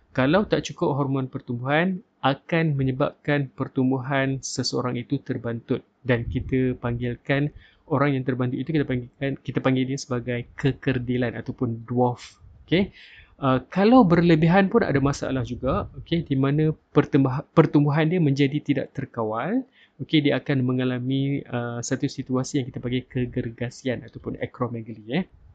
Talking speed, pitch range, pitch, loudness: 135 wpm, 125-145 Hz, 135 Hz, -24 LUFS